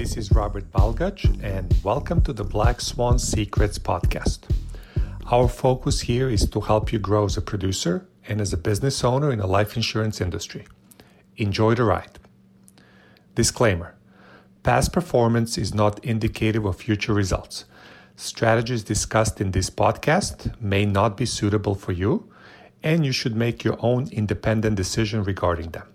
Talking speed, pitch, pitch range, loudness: 155 wpm, 105 Hz, 100-115 Hz, -23 LUFS